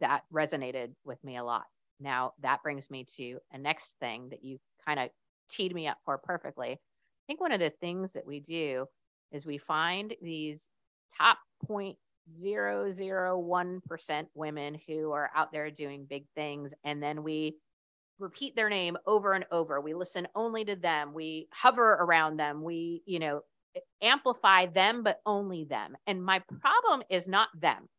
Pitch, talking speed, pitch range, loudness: 160 Hz, 165 wpm, 145-190 Hz, -31 LUFS